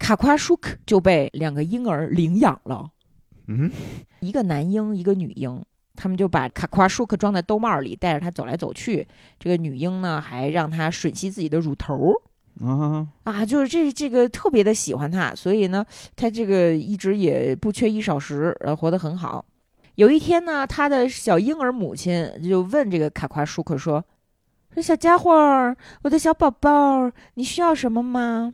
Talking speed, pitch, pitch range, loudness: 260 characters per minute, 190 Hz, 160-245 Hz, -21 LUFS